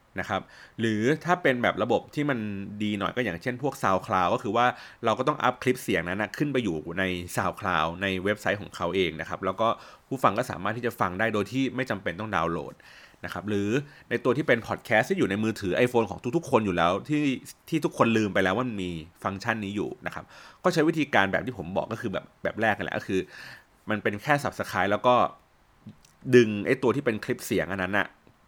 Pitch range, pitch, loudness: 95-125 Hz, 110 Hz, -27 LUFS